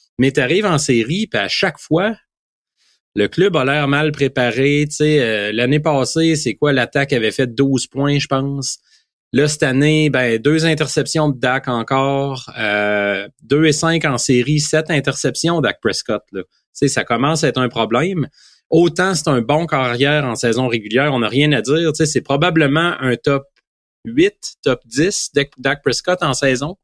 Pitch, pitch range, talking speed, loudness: 140 Hz, 130-155 Hz, 180 wpm, -16 LUFS